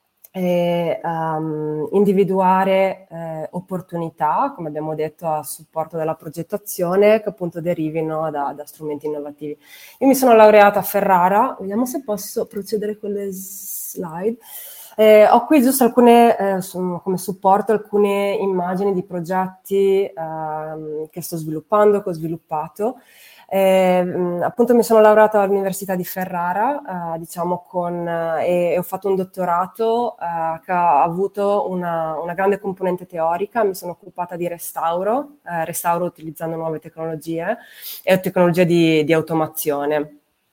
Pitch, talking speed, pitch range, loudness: 180 Hz, 135 wpm, 165-200 Hz, -19 LUFS